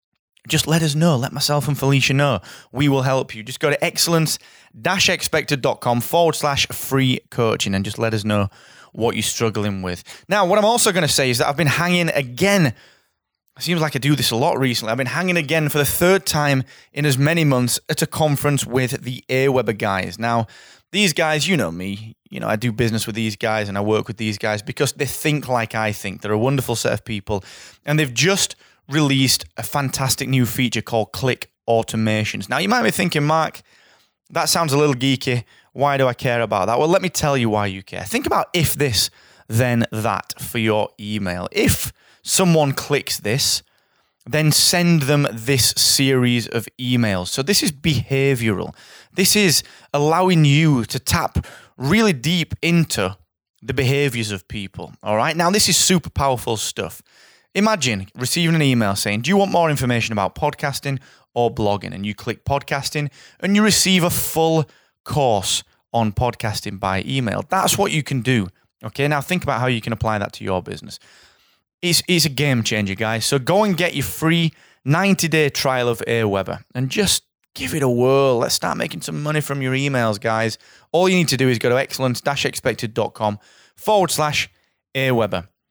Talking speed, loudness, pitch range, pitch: 190 wpm, -19 LUFS, 115-155 Hz, 130 Hz